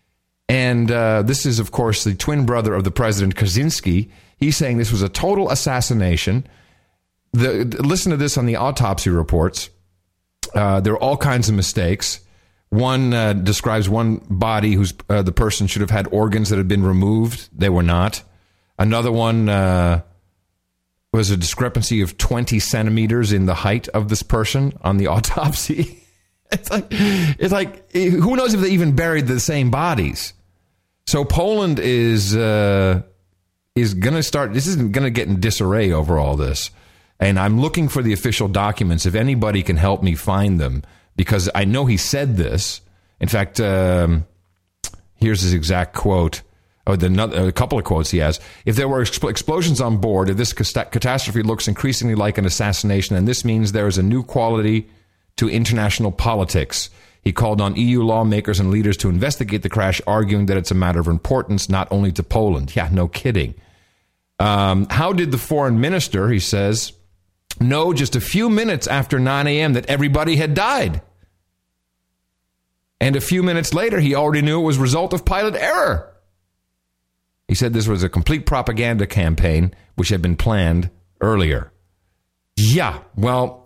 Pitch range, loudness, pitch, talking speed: 90-125 Hz, -18 LUFS, 105 Hz, 175 wpm